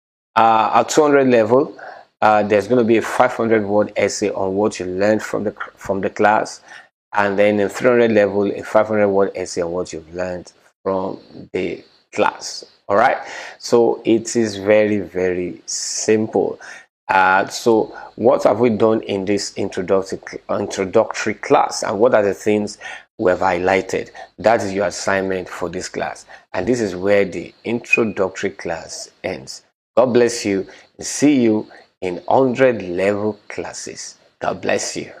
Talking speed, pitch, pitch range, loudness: 160 wpm, 105 Hz, 95-110 Hz, -18 LUFS